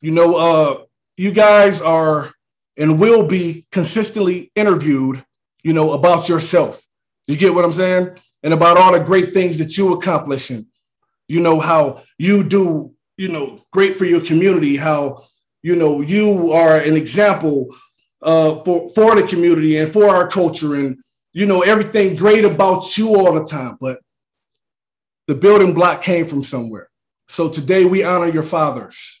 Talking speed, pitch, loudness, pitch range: 165 wpm, 170 Hz, -14 LUFS, 155-190 Hz